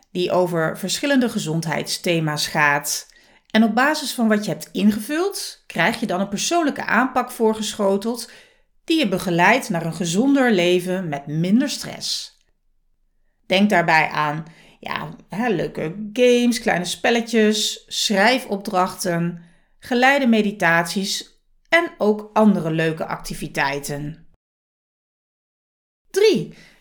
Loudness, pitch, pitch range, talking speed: -20 LUFS, 205 Hz, 170-245 Hz, 105 wpm